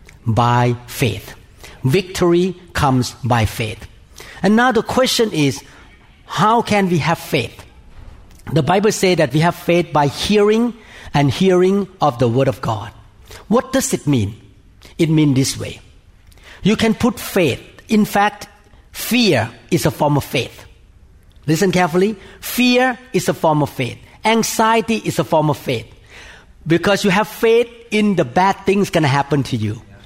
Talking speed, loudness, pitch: 155 wpm, -17 LUFS, 155 Hz